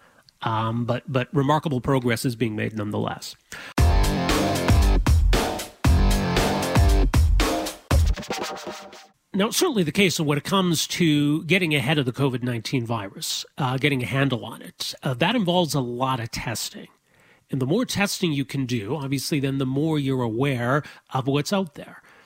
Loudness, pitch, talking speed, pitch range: -23 LUFS, 135 Hz, 150 wpm, 120-155 Hz